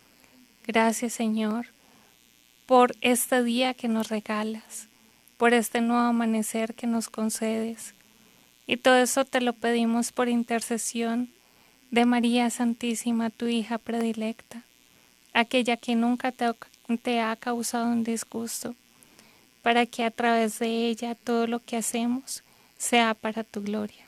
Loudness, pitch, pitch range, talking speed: -26 LUFS, 235 Hz, 225-240 Hz, 130 wpm